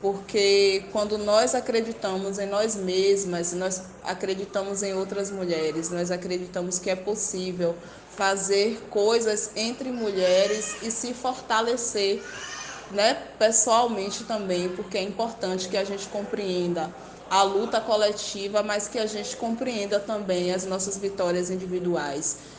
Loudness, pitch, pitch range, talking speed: -26 LUFS, 200 Hz, 185-215 Hz, 125 wpm